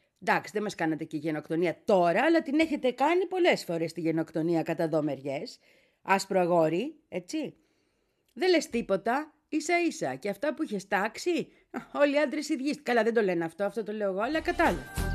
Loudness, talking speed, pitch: -28 LUFS, 175 wpm, 215 Hz